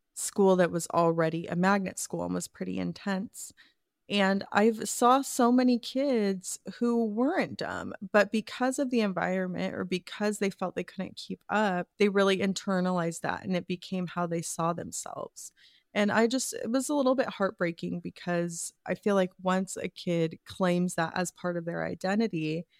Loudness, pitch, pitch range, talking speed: -29 LUFS, 190 Hz, 175-220 Hz, 175 wpm